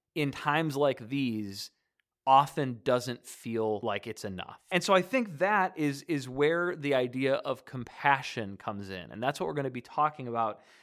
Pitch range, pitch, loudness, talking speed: 120-150 Hz, 135 Hz, -30 LUFS, 185 wpm